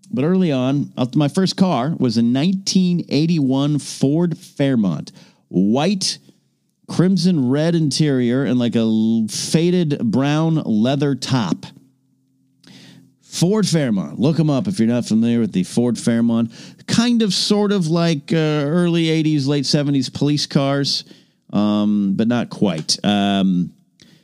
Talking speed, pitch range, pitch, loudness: 130 wpm, 125-175 Hz, 145 Hz, -18 LUFS